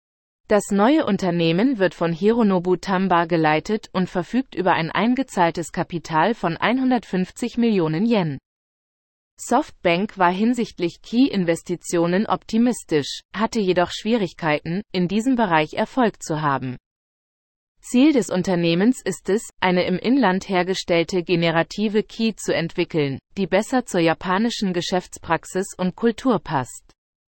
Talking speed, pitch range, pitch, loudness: 115 wpm, 170-220 Hz, 185 Hz, -21 LUFS